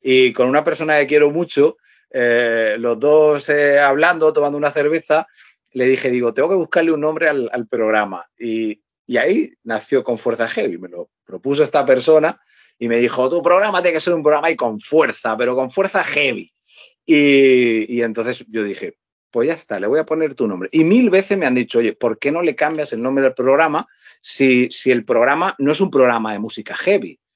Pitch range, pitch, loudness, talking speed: 120-160 Hz, 140 Hz, -16 LUFS, 210 wpm